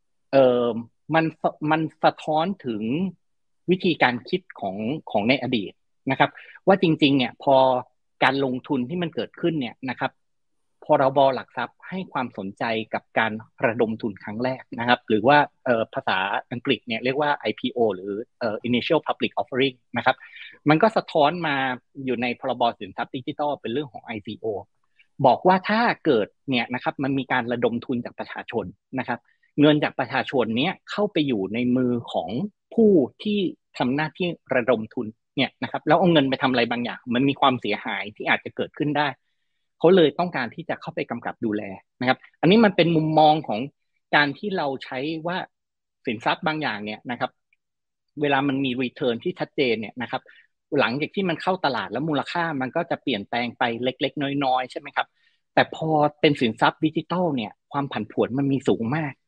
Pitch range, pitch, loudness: 125-160 Hz, 140 Hz, -23 LUFS